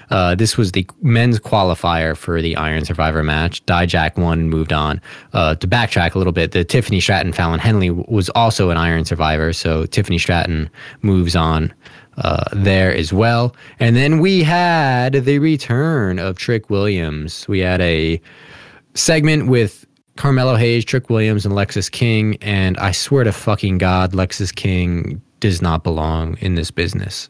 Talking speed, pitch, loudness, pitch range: 170 wpm, 95 Hz, -16 LUFS, 85-115 Hz